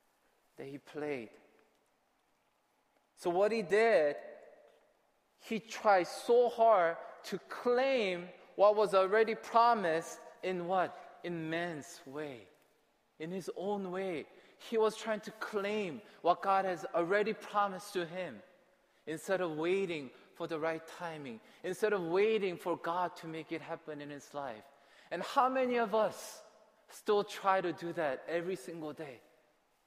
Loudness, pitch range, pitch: -34 LUFS, 165-210 Hz, 185 Hz